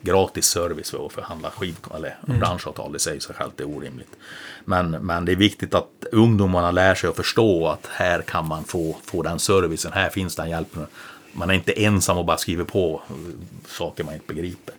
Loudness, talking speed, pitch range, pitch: -22 LUFS, 195 wpm, 85-95 Hz, 90 Hz